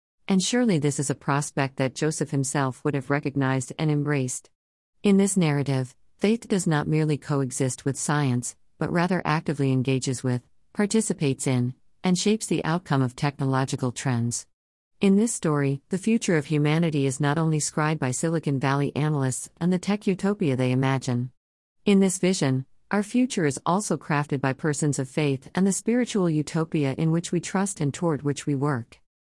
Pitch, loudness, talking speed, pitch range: 150 Hz, -25 LUFS, 175 wpm, 135-175 Hz